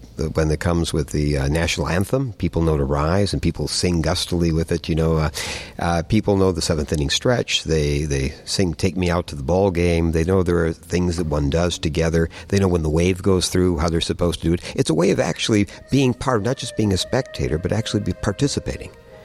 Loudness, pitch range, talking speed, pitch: -20 LUFS, 80-95 Hz, 240 wpm, 85 Hz